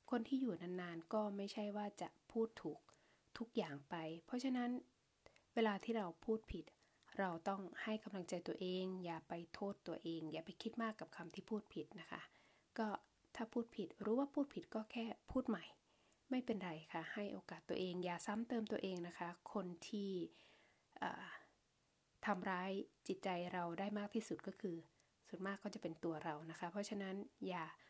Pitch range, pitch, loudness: 175-225 Hz, 200 Hz, -46 LUFS